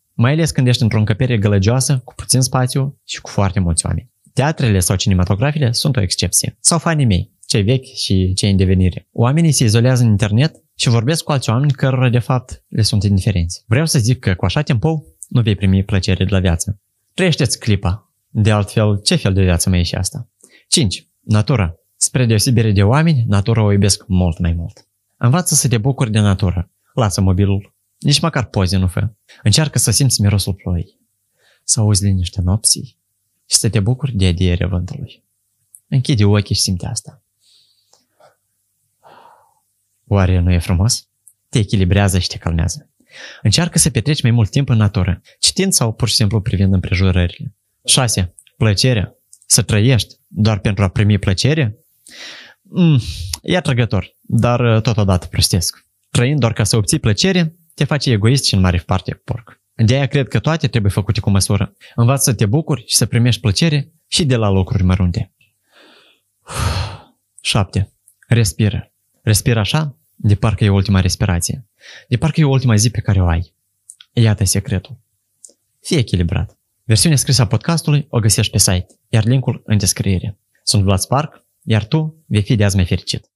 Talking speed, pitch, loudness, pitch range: 170 wpm, 110 Hz, -16 LUFS, 100-130 Hz